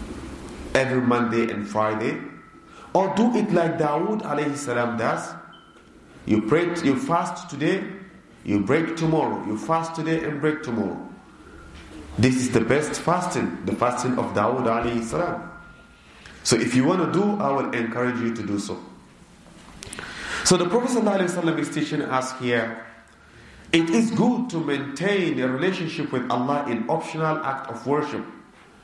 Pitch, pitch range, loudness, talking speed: 140 Hz, 115-170 Hz, -23 LUFS, 140 wpm